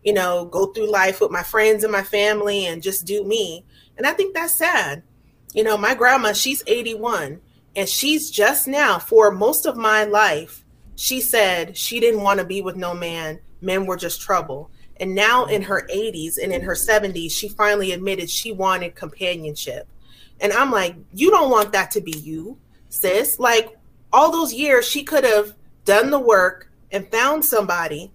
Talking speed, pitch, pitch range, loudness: 190 wpm, 210 Hz, 185-235 Hz, -19 LUFS